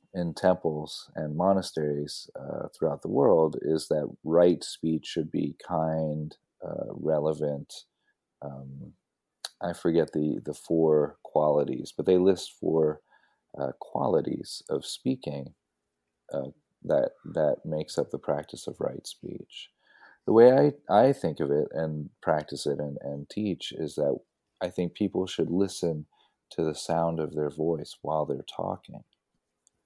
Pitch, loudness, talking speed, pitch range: 80 Hz, -28 LUFS, 145 wpm, 75-85 Hz